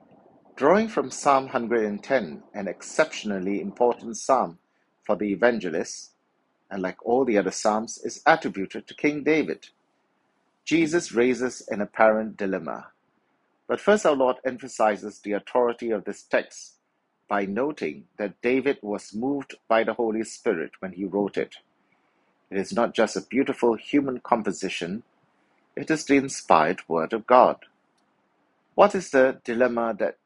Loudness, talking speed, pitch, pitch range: -25 LUFS, 140 wpm, 120 Hz, 105-135 Hz